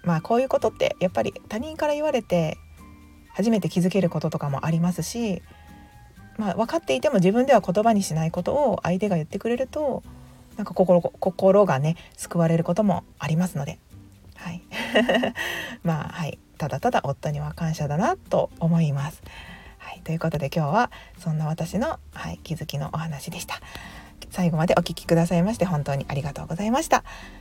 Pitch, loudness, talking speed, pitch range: 170 Hz, -24 LUFS, 370 characters per minute, 155-200 Hz